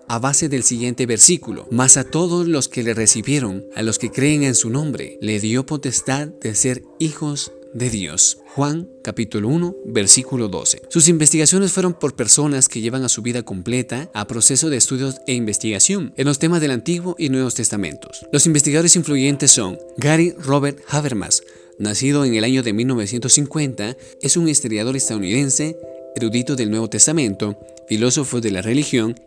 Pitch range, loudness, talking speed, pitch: 115-150 Hz, -16 LUFS, 170 wpm, 130 Hz